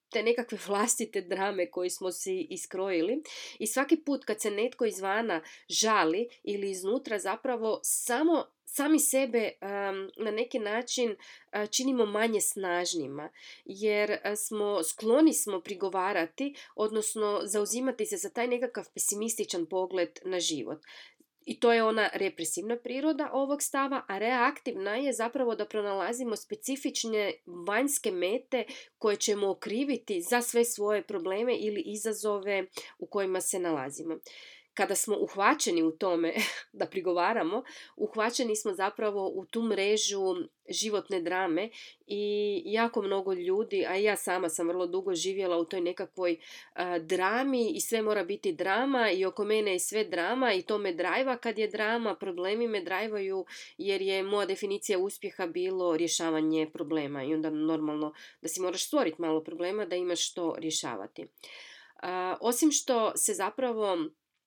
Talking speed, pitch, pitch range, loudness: 145 wpm, 210 Hz, 185-240 Hz, -30 LUFS